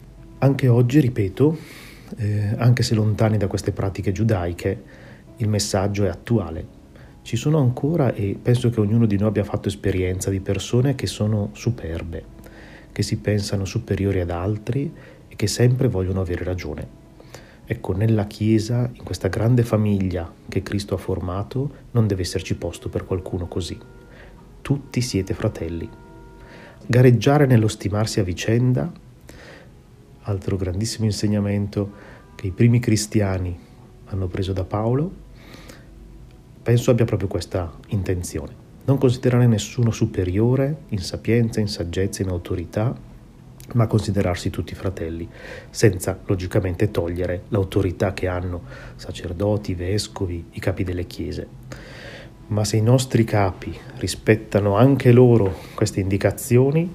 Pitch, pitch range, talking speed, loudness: 105 Hz, 95-120 Hz, 130 wpm, -22 LUFS